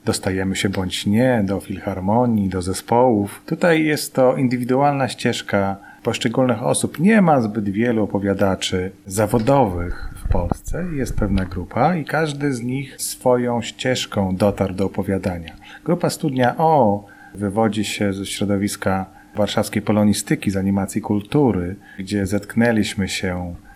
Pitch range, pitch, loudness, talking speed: 100-125 Hz, 105 Hz, -20 LUFS, 125 wpm